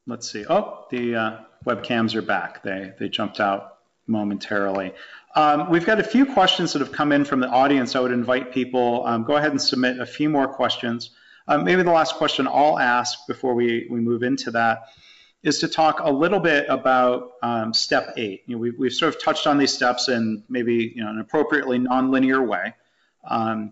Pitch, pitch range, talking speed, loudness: 125 Hz, 115-140 Hz, 205 wpm, -21 LUFS